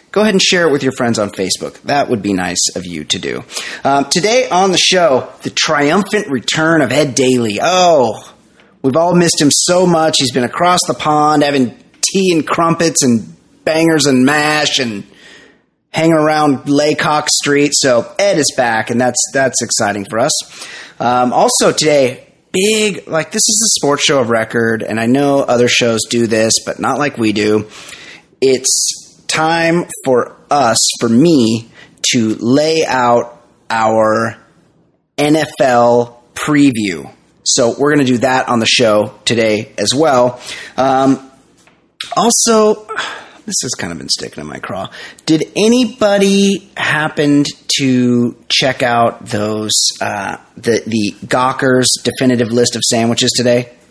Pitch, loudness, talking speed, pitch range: 135 Hz, -12 LUFS, 155 wpm, 120-160 Hz